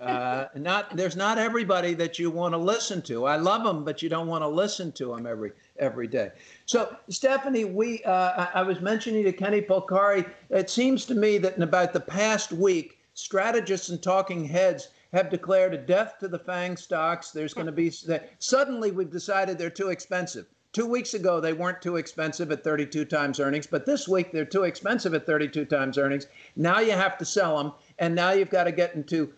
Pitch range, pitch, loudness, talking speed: 160-200 Hz, 180 Hz, -26 LUFS, 205 wpm